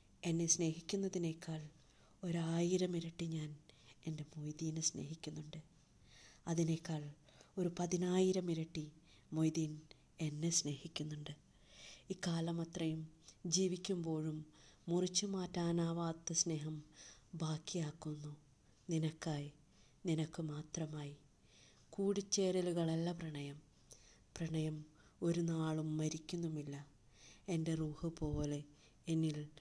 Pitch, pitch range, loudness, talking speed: 160 Hz, 150-170 Hz, -41 LUFS, 70 wpm